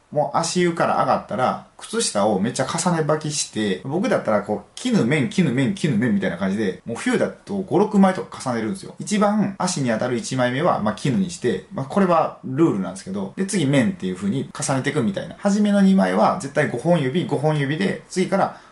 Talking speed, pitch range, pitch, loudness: 395 characters per minute, 145-195 Hz, 175 Hz, -21 LUFS